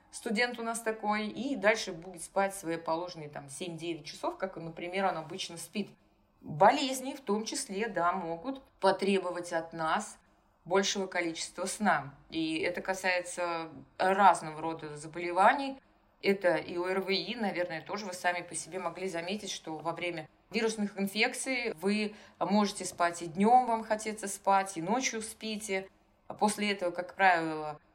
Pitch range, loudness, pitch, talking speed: 170-210 Hz, -32 LUFS, 190 Hz, 145 wpm